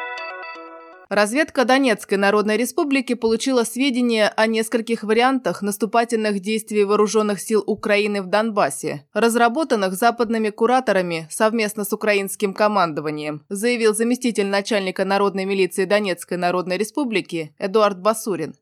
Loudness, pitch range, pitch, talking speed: -20 LUFS, 200-230 Hz, 210 Hz, 105 wpm